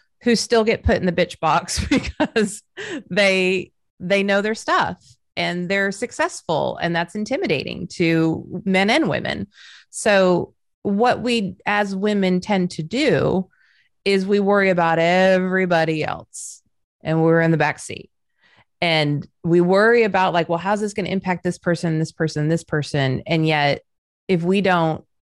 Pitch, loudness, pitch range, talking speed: 185 Hz, -20 LUFS, 165-205 Hz, 155 wpm